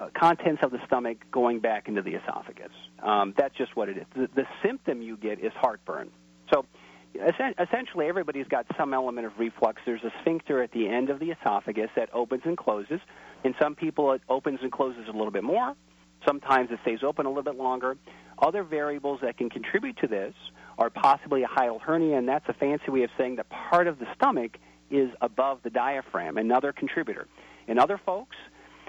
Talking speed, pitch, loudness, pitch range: 195 wpm, 130 Hz, -28 LUFS, 115-150 Hz